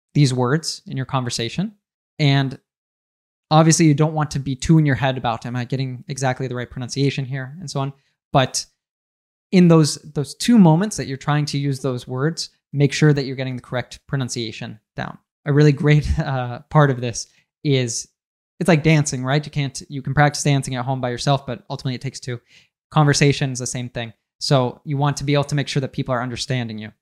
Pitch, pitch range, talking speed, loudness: 140 Hz, 125-150 Hz, 215 wpm, -20 LUFS